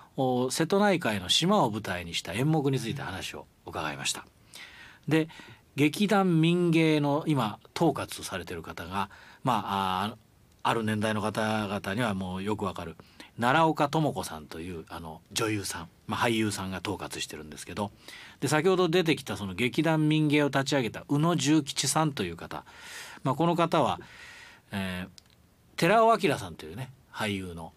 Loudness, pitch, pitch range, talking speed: -28 LUFS, 115 Hz, 95-155 Hz, 305 characters per minute